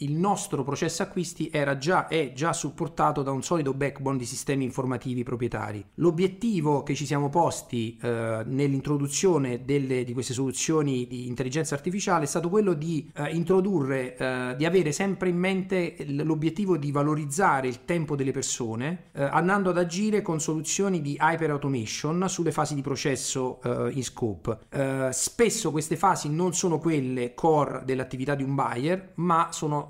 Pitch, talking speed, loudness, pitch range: 145 Hz, 160 wpm, -27 LUFS, 130-170 Hz